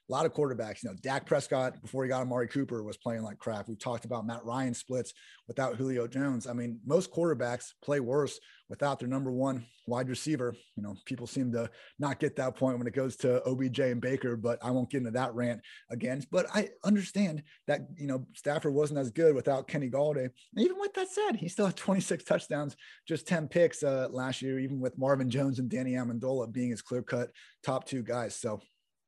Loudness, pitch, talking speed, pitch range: -33 LUFS, 130 Hz, 215 wpm, 120-145 Hz